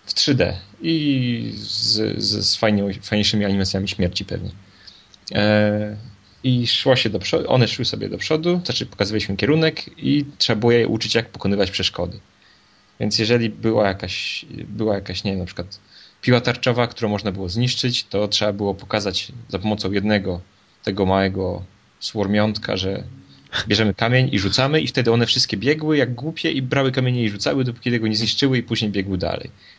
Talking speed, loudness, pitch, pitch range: 170 wpm, -20 LUFS, 105 Hz, 100-120 Hz